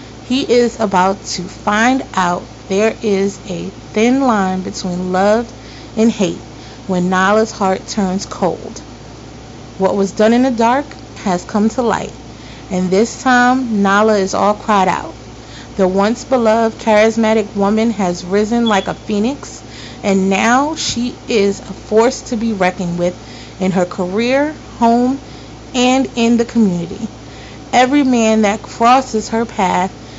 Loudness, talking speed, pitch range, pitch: -15 LUFS, 145 wpm, 185-235 Hz, 210 Hz